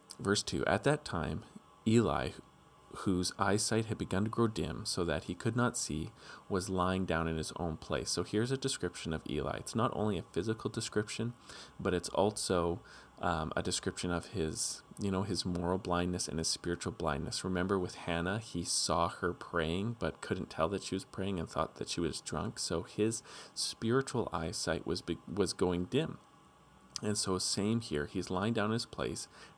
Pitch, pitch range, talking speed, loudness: 95 Hz, 85-110 Hz, 190 wpm, -35 LUFS